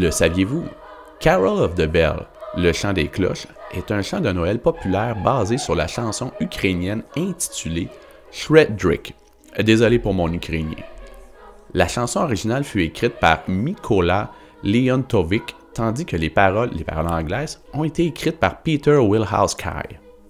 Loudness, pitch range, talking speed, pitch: -20 LUFS, 95-140 Hz, 140 wpm, 115 Hz